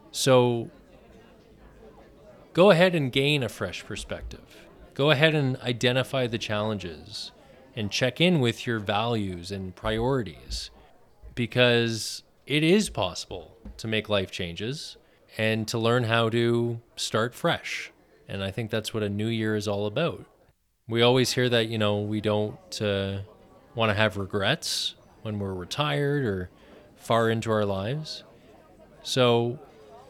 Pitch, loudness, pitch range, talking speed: 115 Hz, -26 LUFS, 105-125 Hz, 140 wpm